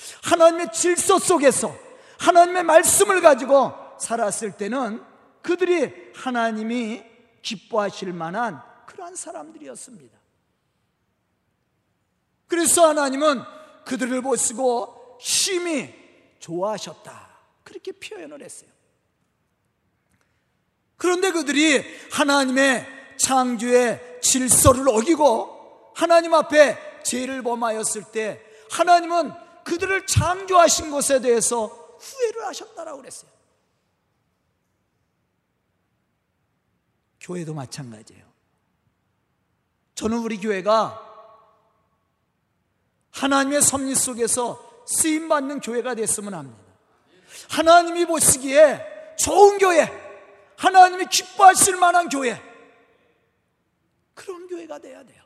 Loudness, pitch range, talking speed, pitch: -19 LUFS, 230-340 Hz, 225 characters per minute, 275 Hz